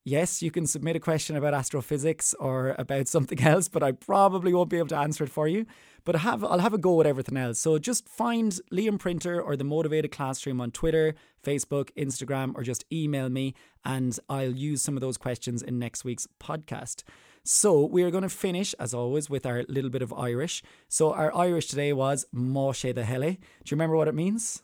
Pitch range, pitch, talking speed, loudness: 130-170 Hz, 150 Hz, 215 wpm, -27 LUFS